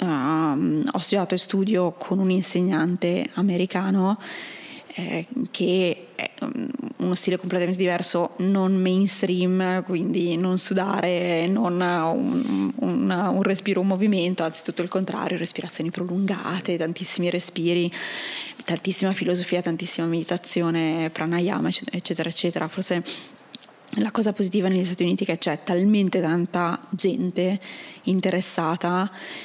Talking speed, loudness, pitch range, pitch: 120 wpm, -24 LUFS, 175-195 Hz, 180 Hz